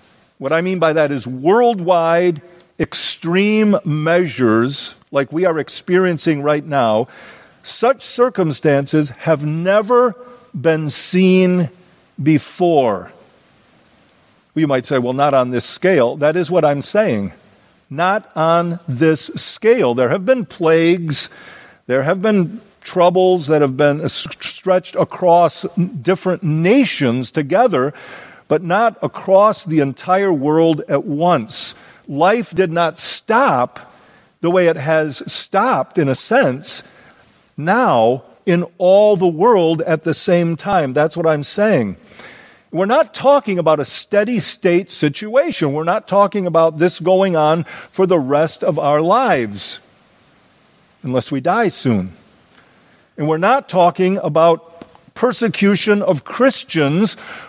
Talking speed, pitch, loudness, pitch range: 125 wpm, 170 Hz, -16 LUFS, 155-190 Hz